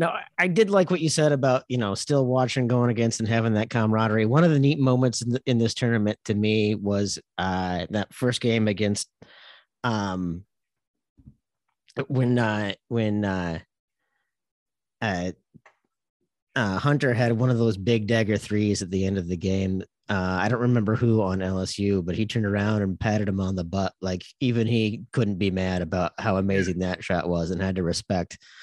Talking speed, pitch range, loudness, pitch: 185 wpm, 95-120 Hz, -24 LUFS, 105 Hz